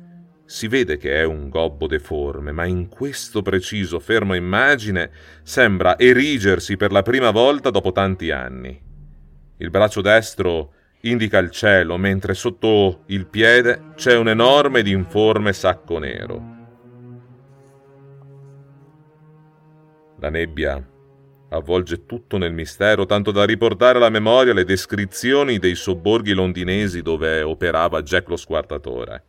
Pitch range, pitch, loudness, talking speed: 90-125 Hz, 105 Hz, -18 LUFS, 125 wpm